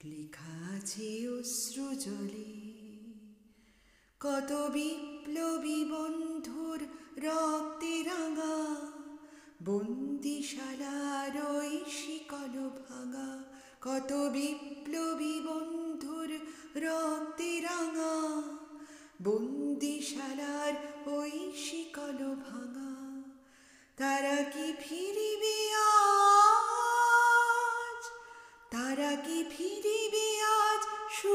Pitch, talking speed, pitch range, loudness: 295 Hz, 35 wpm, 270-325 Hz, -33 LUFS